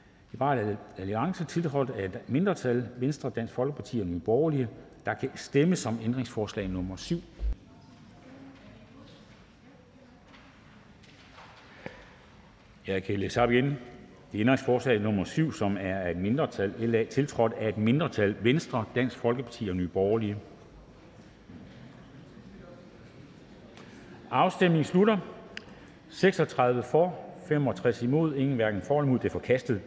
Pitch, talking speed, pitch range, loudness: 120 Hz, 125 wpm, 105-140 Hz, -29 LUFS